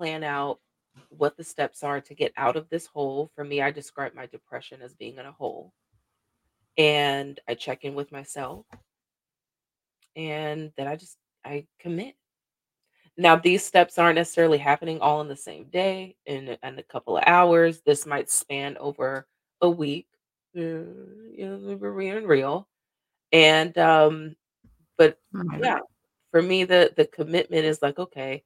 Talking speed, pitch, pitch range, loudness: 160 wpm, 155 Hz, 140-170 Hz, -23 LUFS